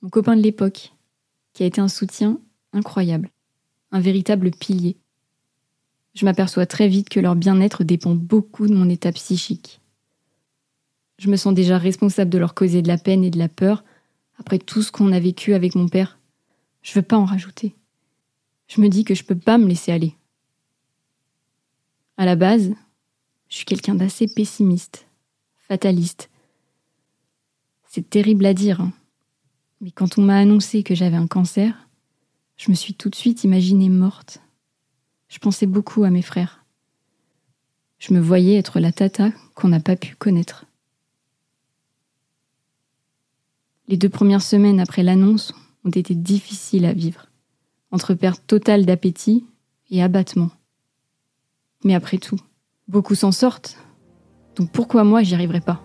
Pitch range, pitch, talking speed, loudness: 155-200 Hz, 185 Hz, 155 wpm, -18 LUFS